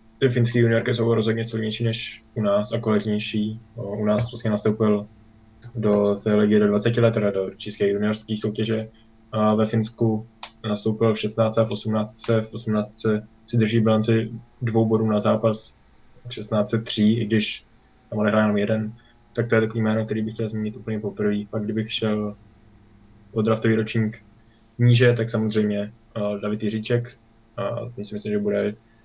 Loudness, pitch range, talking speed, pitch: -23 LUFS, 105-115 Hz, 165 wpm, 110 Hz